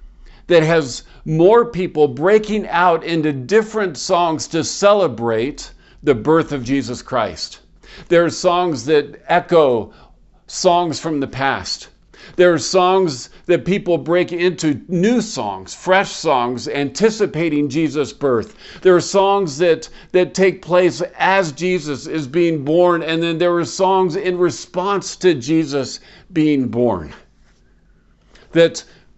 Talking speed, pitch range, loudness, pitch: 130 wpm, 150-180 Hz, -17 LUFS, 170 Hz